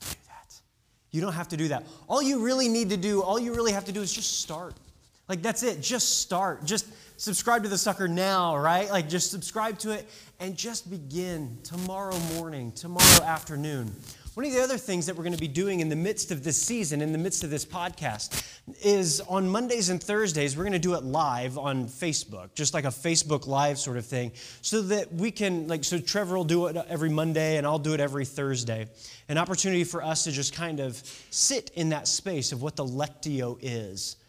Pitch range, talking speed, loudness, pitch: 145-195 Hz, 215 wpm, -27 LUFS, 165 Hz